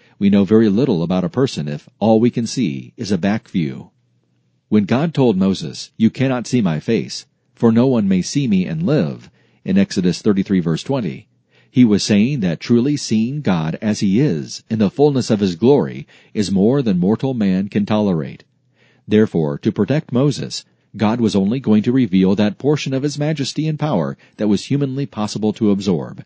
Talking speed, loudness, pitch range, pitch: 190 wpm, -17 LUFS, 100-140 Hz, 110 Hz